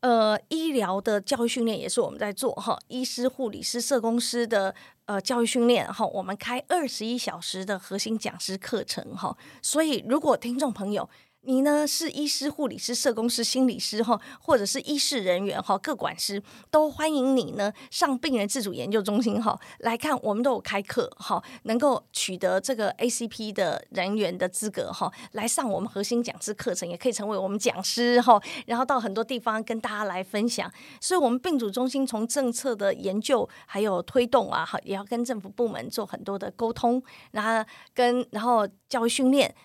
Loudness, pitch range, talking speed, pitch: -27 LUFS, 205-260 Hz, 295 characters per minute, 235 Hz